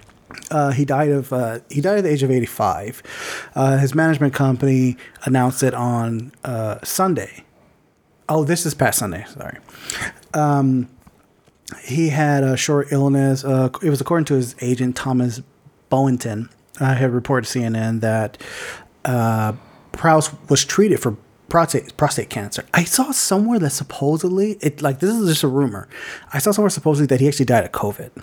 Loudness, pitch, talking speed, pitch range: -19 LUFS, 135 Hz, 170 wpm, 125-150 Hz